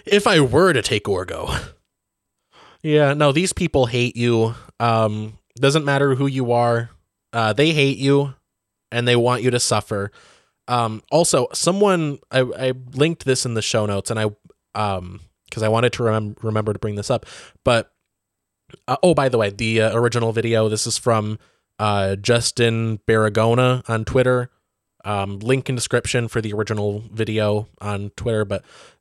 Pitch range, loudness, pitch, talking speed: 110-130 Hz, -20 LUFS, 115 Hz, 170 wpm